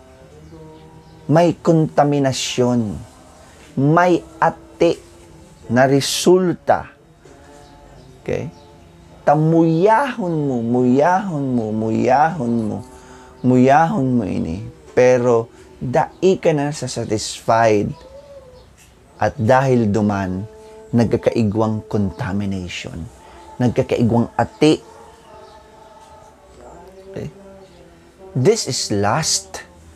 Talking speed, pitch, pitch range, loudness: 65 wpm, 125 Hz, 110-165 Hz, -17 LUFS